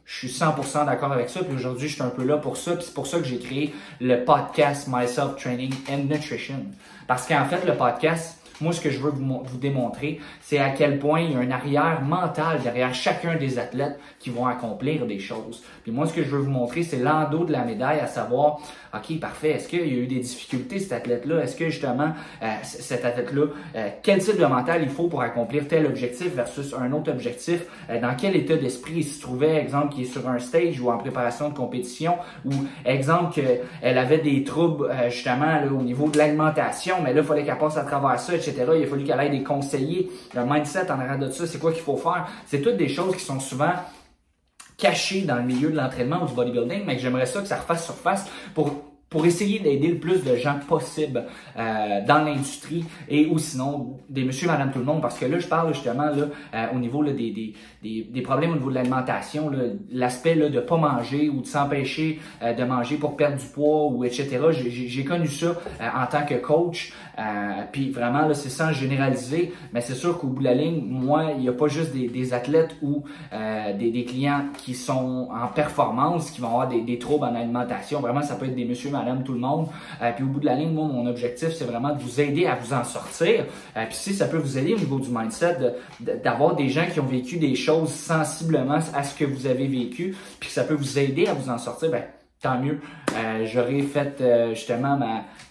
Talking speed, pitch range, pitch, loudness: 235 wpm, 125-155 Hz, 140 Hz, -24 LUFS